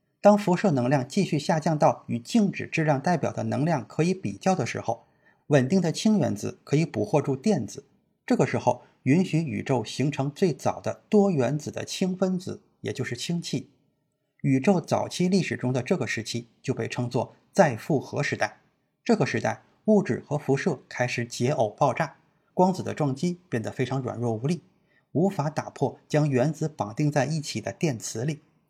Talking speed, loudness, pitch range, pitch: 270 characters per minute, -26 LUFS, 125-175 Hz, 145 Hz